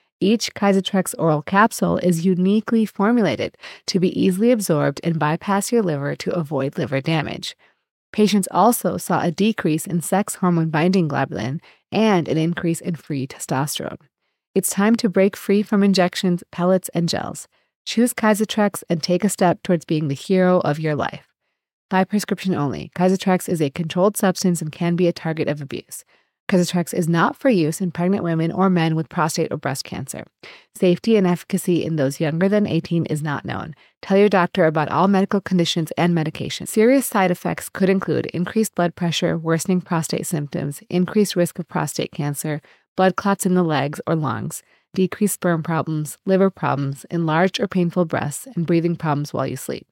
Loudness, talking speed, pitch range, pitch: -20 LUFS, 175 wpm, 160-195 Hz, 175 Hz